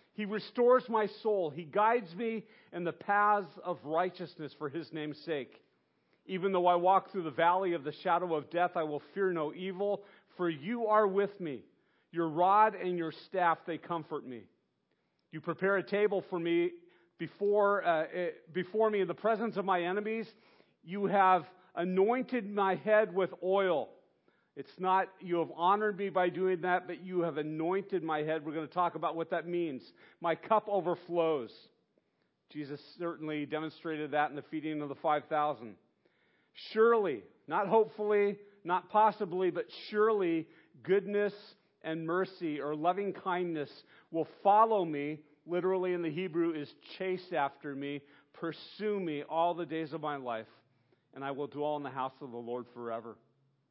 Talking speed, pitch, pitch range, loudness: 165 wpm, 175 Hz, 155-200 Hz, -33 LUFS